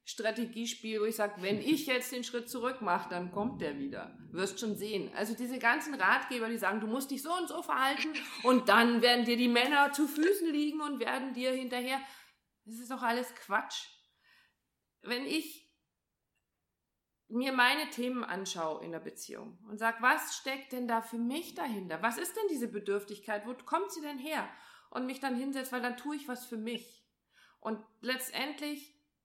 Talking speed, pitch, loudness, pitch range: 185 wpm, 245 Hz, -33 LUFS, 220-275 Hz